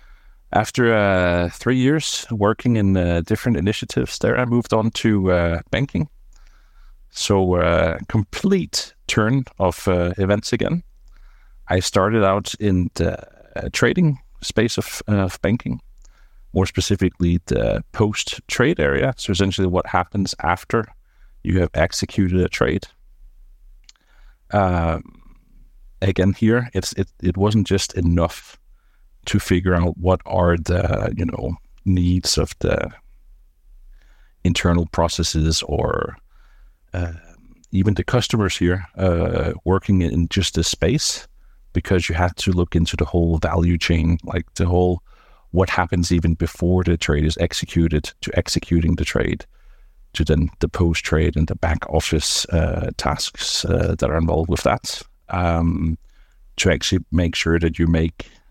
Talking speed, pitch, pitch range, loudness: 140 wpm, 90 Hz, 85-100 Hz, -20 LUFS